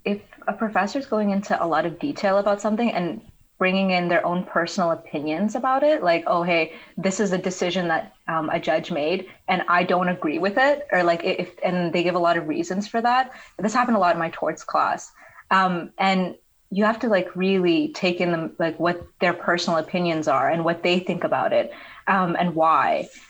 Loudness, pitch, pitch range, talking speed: -22 LUFS, 185 Hz, 170-205 Hz, 215 wpm